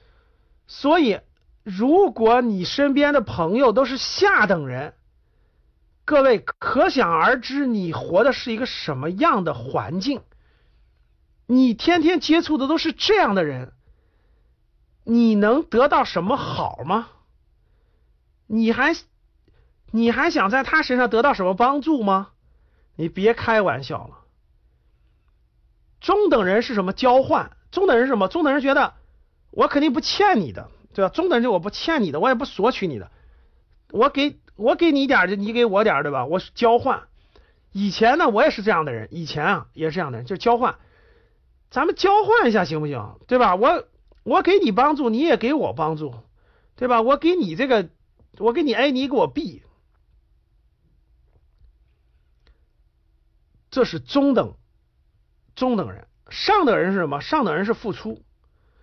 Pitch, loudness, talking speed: 230 Hz, -20 LUFS, 220 characters per minute